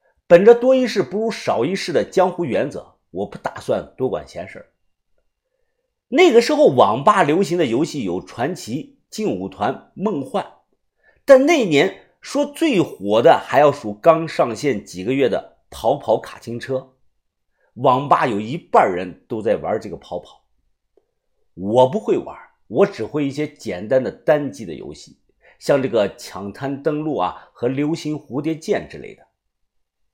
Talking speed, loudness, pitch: 225 characters per minute, -19 LUFS, 160 Hz